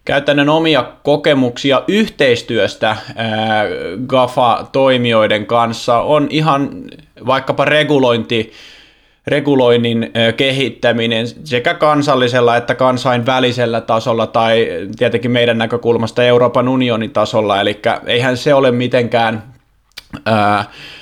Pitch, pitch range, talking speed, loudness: 120 Hz, 115-135 Hz, 90 wpm, -14 LUFS